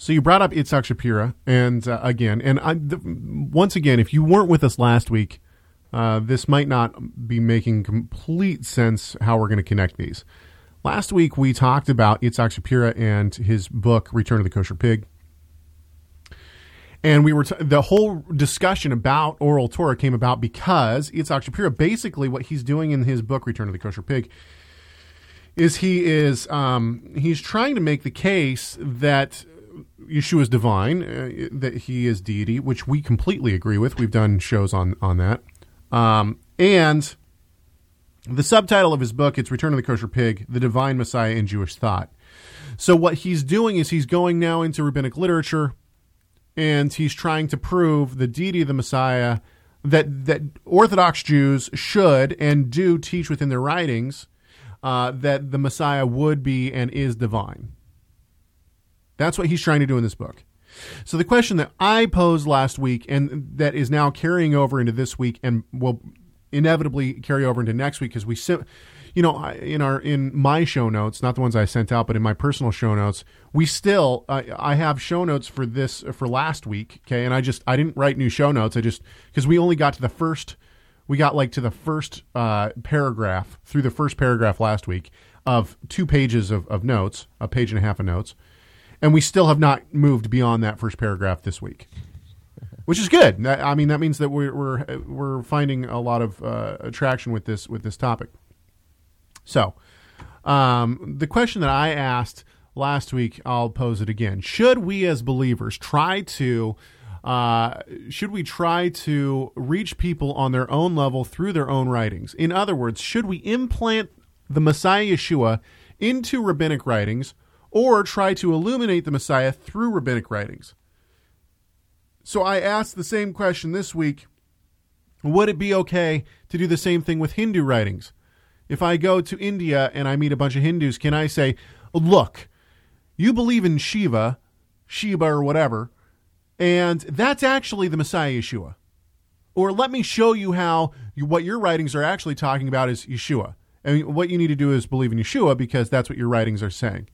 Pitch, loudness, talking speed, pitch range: 130 Hz, -21 LUFS, 185 wpm, 110-155 Hz